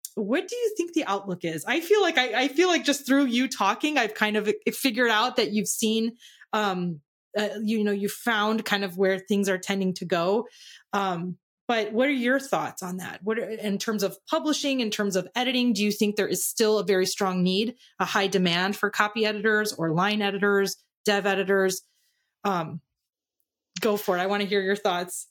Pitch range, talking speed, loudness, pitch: 195-235 Hz, 210 wpm, -25 LUFS, 210 Hz